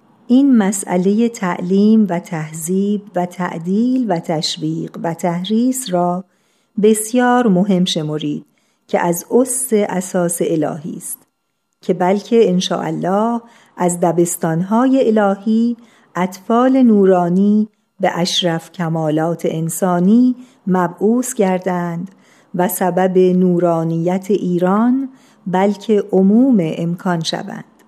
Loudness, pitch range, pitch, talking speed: -16 LUFS, 175-220 Hz, 190 Hz, 95 wpm